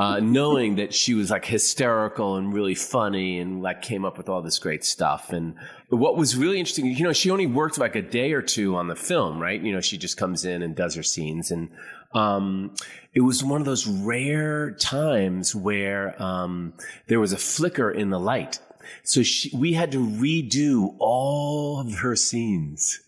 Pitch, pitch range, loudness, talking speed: 105 Hz, 95-135 Hz, -24 LUFS, 200 wpm